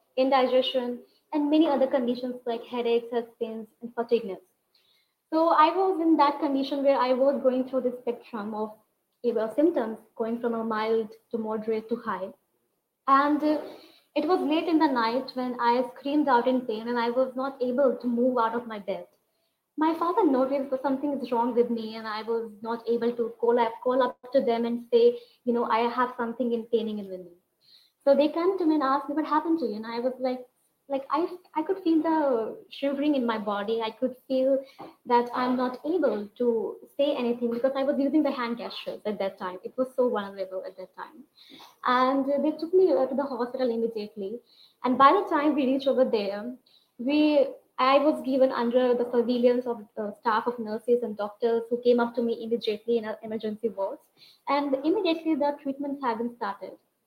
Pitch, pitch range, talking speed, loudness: 250 Hz, 230-280 Hz, 200 wpm, -26 LUFS